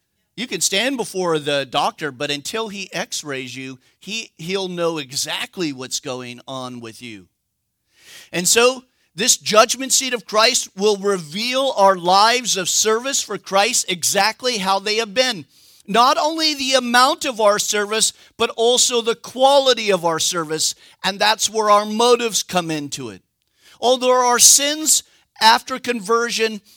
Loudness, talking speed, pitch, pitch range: -17 LUFS, 150 wpm, 210 Hz, 170-240 Hz